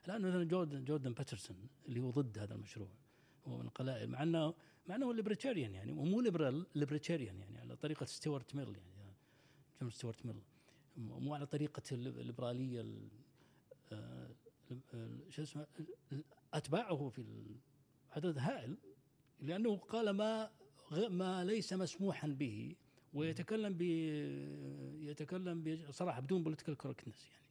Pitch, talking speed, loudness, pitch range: 145 Hz, 125 wpm, -43 LUFS, 125-165 Hz